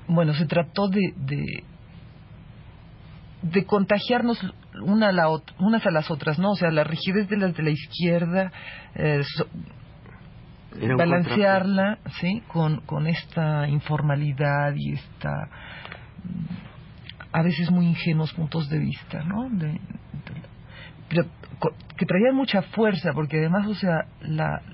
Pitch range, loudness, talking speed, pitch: 150-190 Hz, -24 LUFS, 135 wpm, 165 Hz